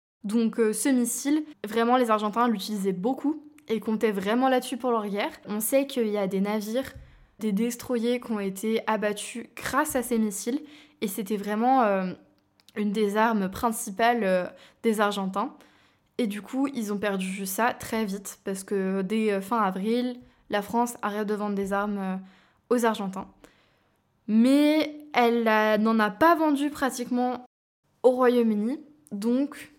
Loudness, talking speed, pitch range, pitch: -26 LUFS, 155 wpm, 205-250 Hz, 225 Hz